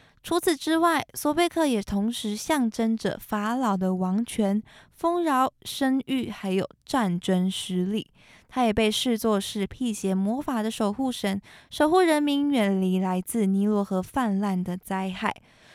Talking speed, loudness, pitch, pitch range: 220 characters per minute, -26 LUFS, 220 Hz, 195-265 Hz